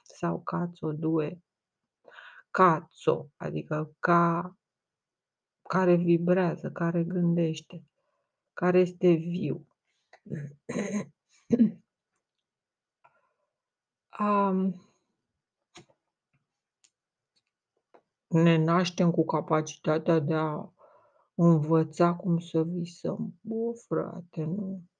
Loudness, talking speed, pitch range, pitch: -28 LUFS, 65 wpm, 160-190 Hz, 175 Hz